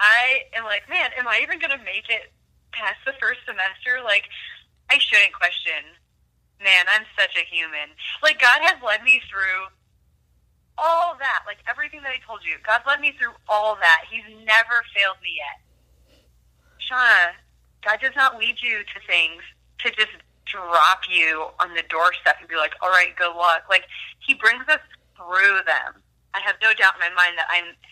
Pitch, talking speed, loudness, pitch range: 205 Hz, 185 wpm, -19 LUFS, 170-255 Hz